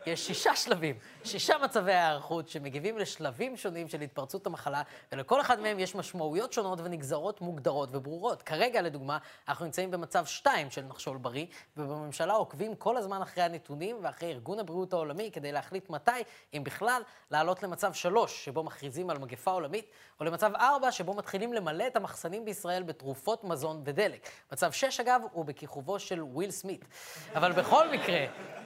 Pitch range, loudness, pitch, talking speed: 150-205 Hz, -33 LUFS, 175 Hz, 160 wpm